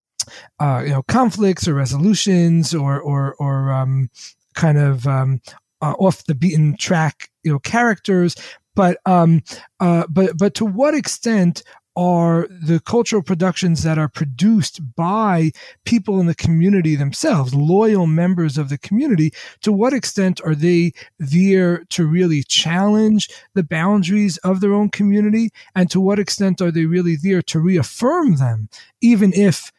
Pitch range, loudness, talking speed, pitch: 155-200 Hz, -17 LUFS, 150 wpm, 175 Hz